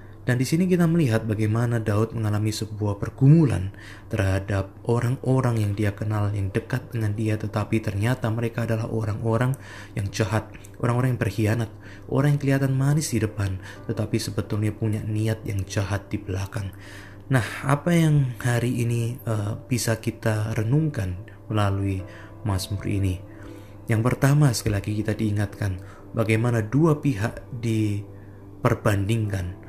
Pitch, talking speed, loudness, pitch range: 110 Hz, 135 wpm, -24 LUFS, 100-120 Hz